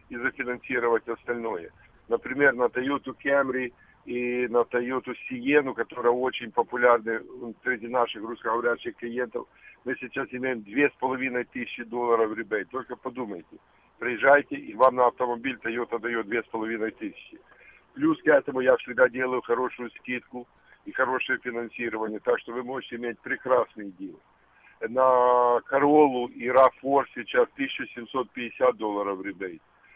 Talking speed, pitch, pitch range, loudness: 125 wpm, 125 Hz, 120-130 Hz, -26 LUFS